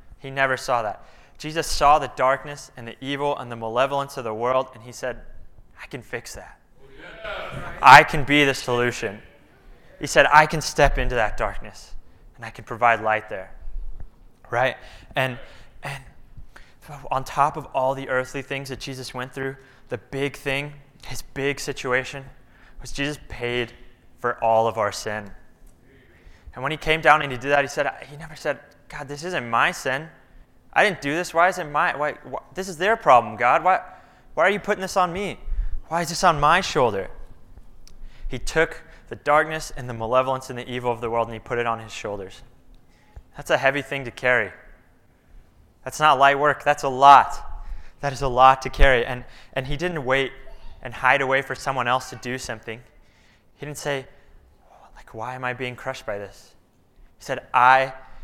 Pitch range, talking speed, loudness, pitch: 120-145 Hz, 190 wpm, -21 LUFS, 130 Hz